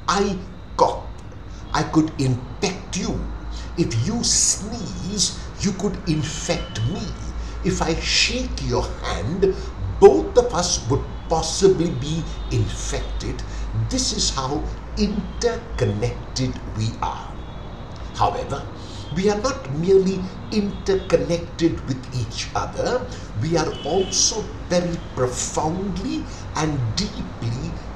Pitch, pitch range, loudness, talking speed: 150 Hz, 115-185 Hz, -22 LUFS, 100 wpm